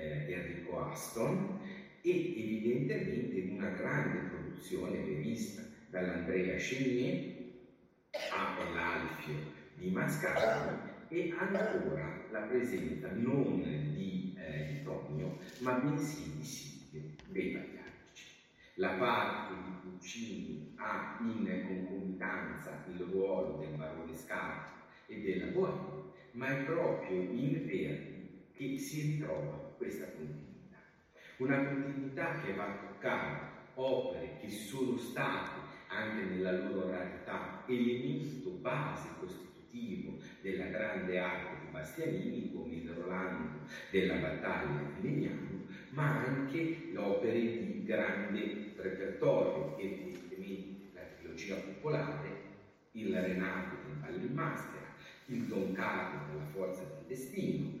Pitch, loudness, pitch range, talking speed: 95 Hz, -38 LUFS, 90-135 Hz, 110 wpm